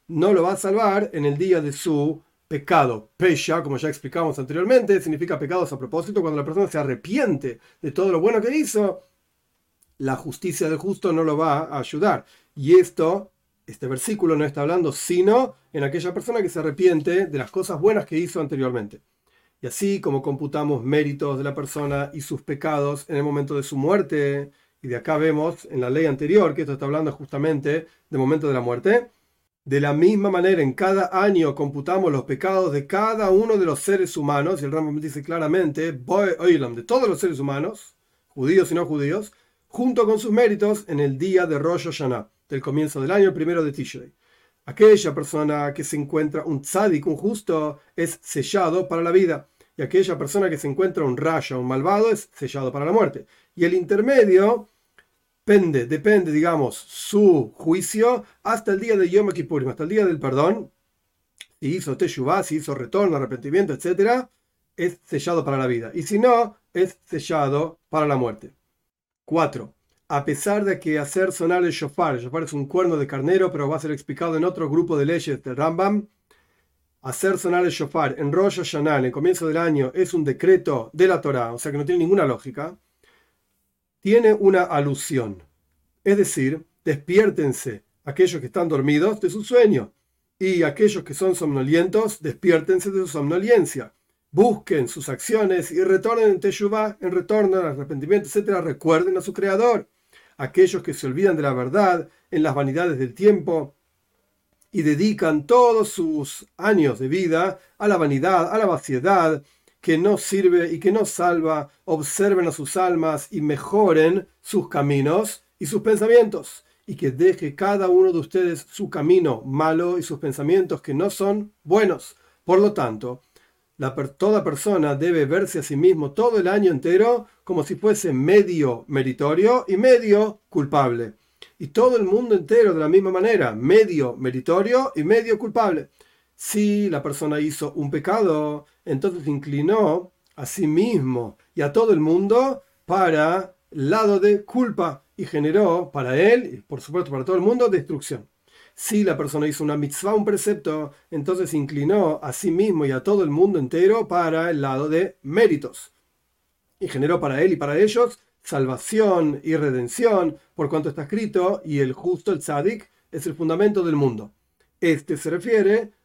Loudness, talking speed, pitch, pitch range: -21 LUFS, 175 wpm, 165 Hz, 145-195 Hz